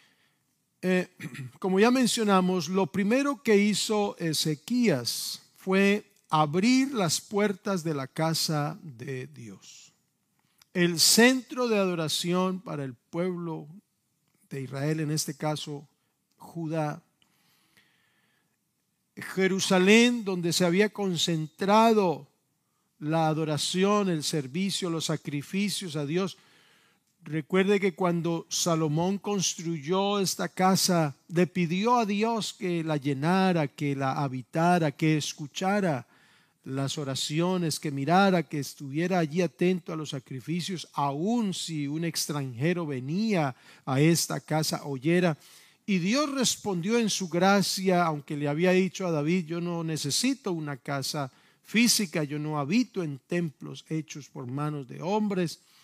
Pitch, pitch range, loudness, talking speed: 170 Hz, 150-190 Hz, -27 LUFS, 120 wpm